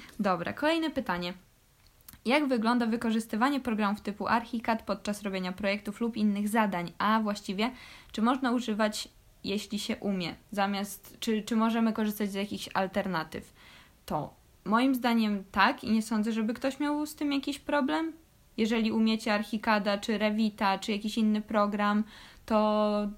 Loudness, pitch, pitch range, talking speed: -30 LUFS, 220 Hz, 205-235 Hz, 140 wpm